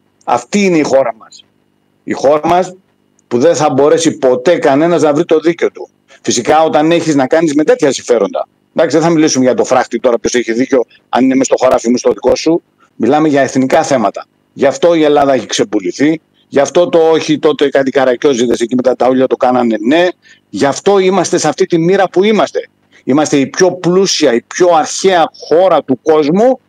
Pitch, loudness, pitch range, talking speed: 155 Hz, -11 LUFS, 135-180 Hz, 200 wpm